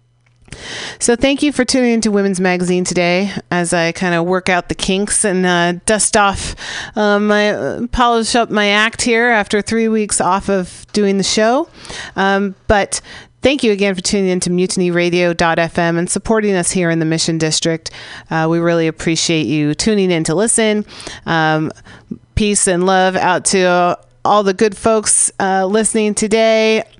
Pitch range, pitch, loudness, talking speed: 175-215 Hz, 195 Hz, -14 LUFS, 175 wpm